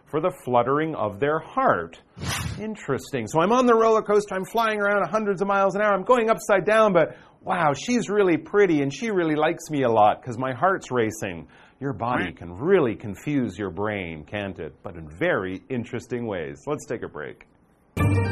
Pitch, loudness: 155 Hz, -23 LUFS